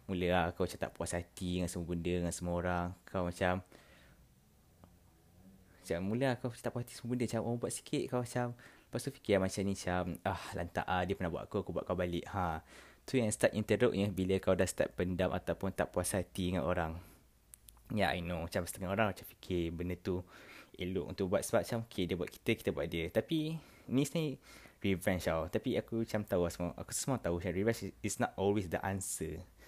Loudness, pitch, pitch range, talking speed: -36 LUFS, 90 Hz, 85-110 Hz, 225 wpm